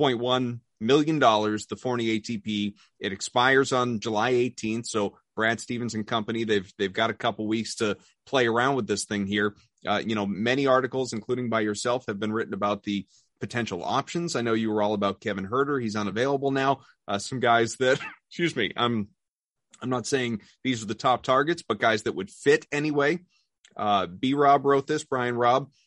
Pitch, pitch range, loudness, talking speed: 115 Hz, 105-130 Hz, -26 LUFS, 195 wpm